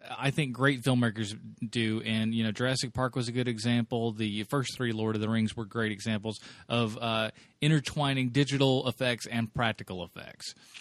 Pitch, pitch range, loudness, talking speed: 120 Hz, 110-130 Hz, -30 LUFS, 180 wpm